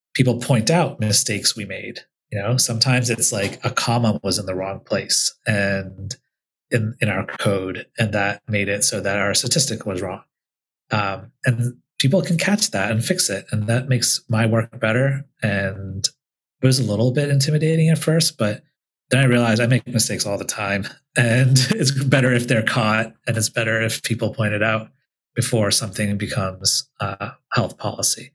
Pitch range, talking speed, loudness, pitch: 105-130 Hz, 185 wpm, -20 LUFS, 115 Hz